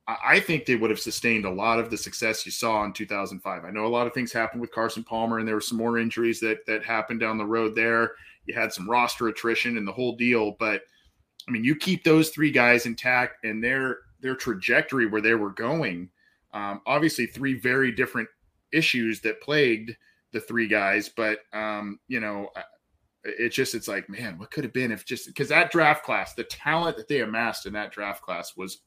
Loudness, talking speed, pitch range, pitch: -25 LUFS, 215 wpm, 110-125 Hz, 115 Hz